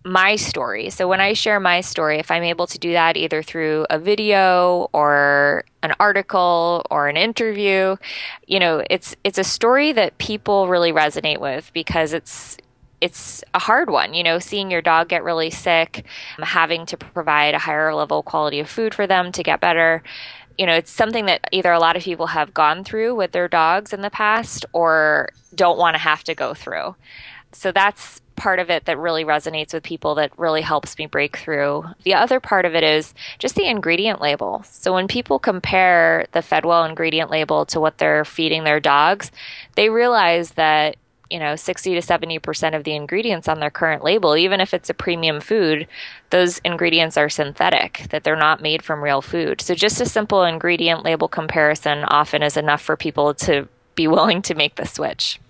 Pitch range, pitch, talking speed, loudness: 155-185 Hz, 165 Hz, 195 wpm, -18 LUFS